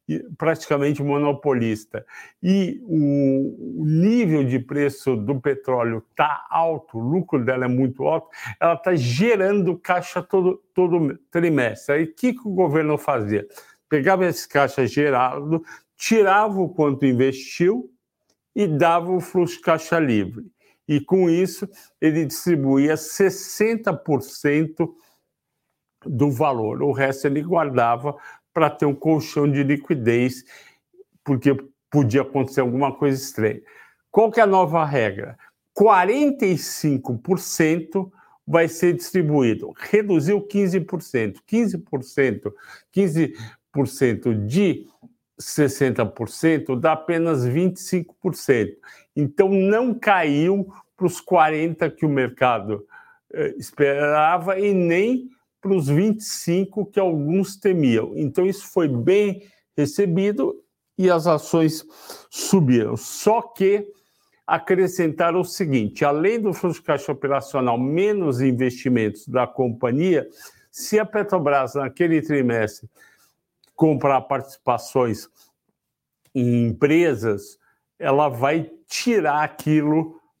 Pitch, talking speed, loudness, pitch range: 155 Hz, 105 wpm, -21 LUFS, 135-185 Hz